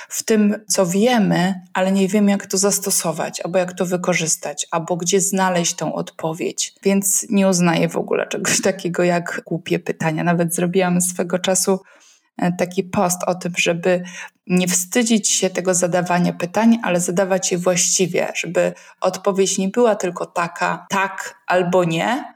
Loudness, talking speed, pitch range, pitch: -19 LUFS, 155 wpm, 180-195 Hz, 185 Hz